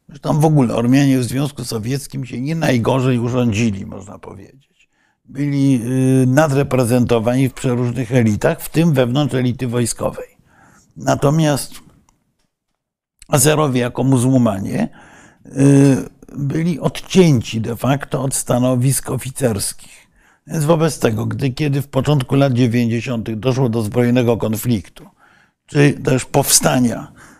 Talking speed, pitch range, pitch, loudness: 110 wpm, 120-140 Hz, 130 Hz, -16 LUFS